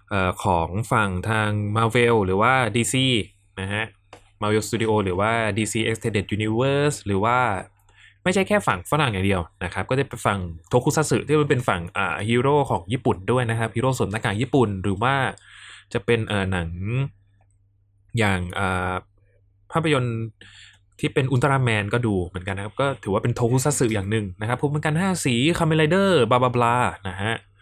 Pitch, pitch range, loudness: 110 Hz, 100-130 Hz, -22 LUFS